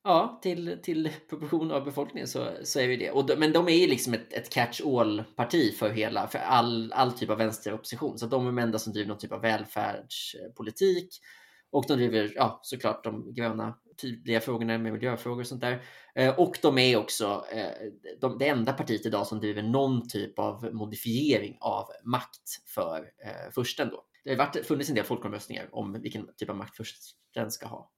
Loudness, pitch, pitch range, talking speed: -29 LUFS, 120 Hz, 110-140 Hz, 195 wpm